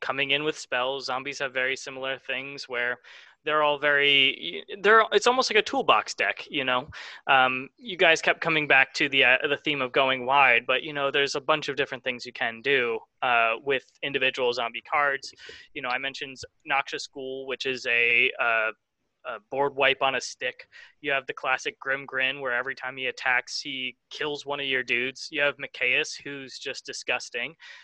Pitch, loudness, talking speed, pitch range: 140 Hz, -25 LUFS, 200 wpm, 130-150 Hz